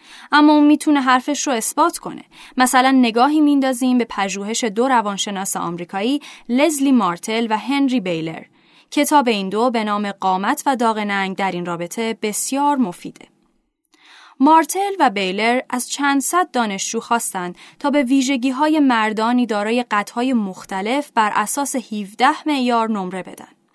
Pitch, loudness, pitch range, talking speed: 245 Hz, -18 LUFS, 210-280 Hz, 135 wpm